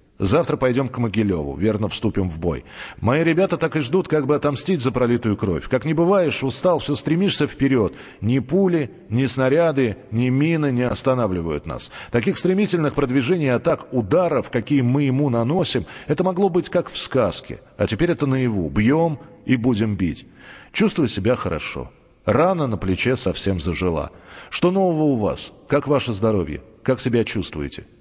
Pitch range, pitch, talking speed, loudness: 105-155 Hz, 130 Hz, 165 wpm, -21 LUFS